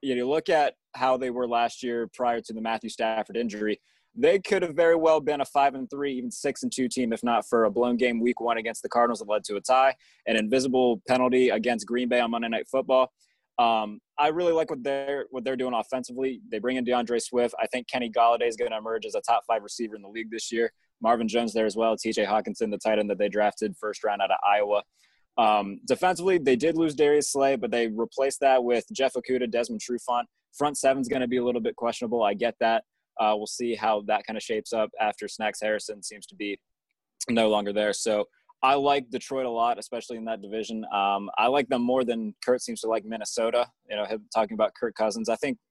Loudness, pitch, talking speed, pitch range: -26 LUFS, 120 Hz, 240 wpm, 110-130 Hz